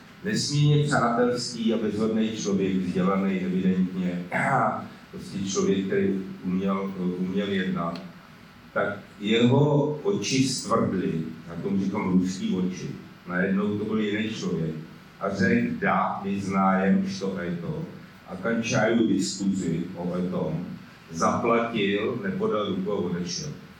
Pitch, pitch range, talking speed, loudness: 95 Hz, 95-115 Hz, 115 wpm, -26 LUFS